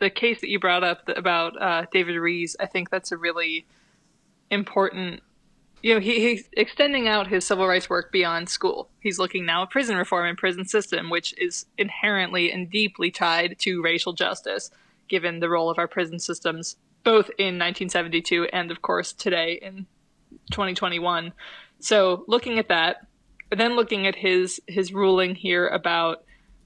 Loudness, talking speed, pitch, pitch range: -23 LUFS, 170 wpm, 185 Hz, 175-205 Hz